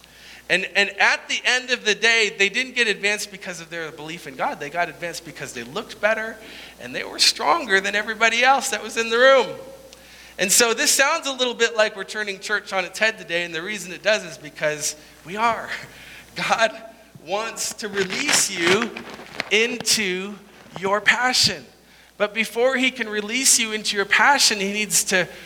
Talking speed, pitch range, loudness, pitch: 190 wpm, 190-230 Hz, -20 LUFS, 210 Hz